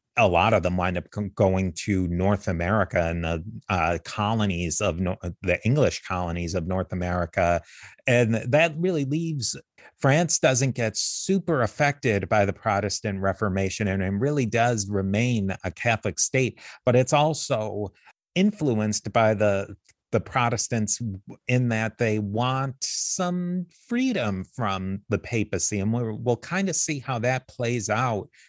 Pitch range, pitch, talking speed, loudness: 95-130 Hz, 110 Hz, 145 wpm, -25 LUFS